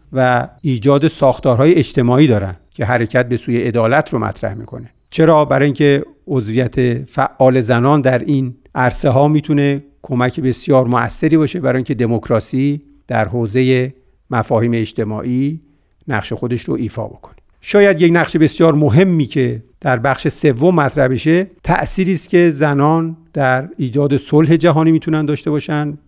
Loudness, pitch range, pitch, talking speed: -15 LUFS, 125-155 Hz, 135 Hz, 145 wpm